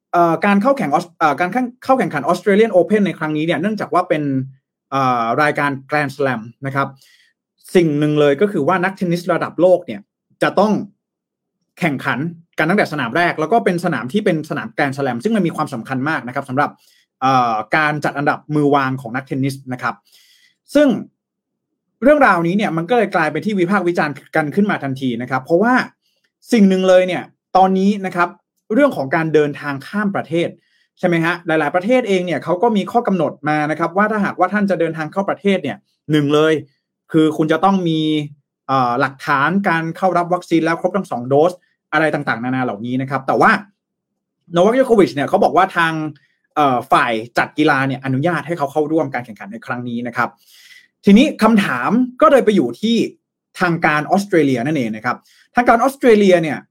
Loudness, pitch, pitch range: -17 LUFS, 170 Hz, 145-200 Hz